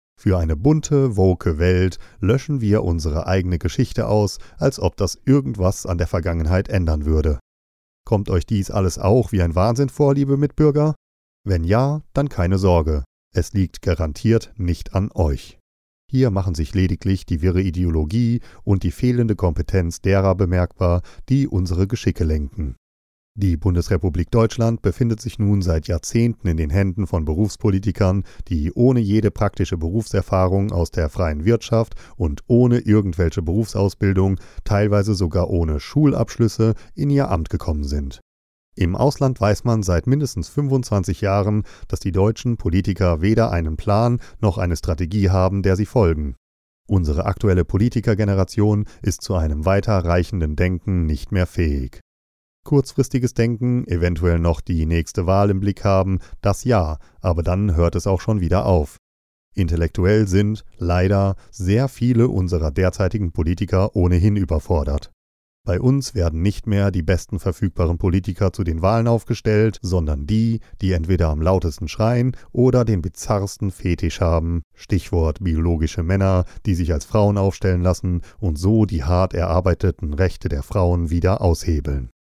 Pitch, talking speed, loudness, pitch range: 95 Hz, 145 wpm, -20 LUFS, 85-105 Hz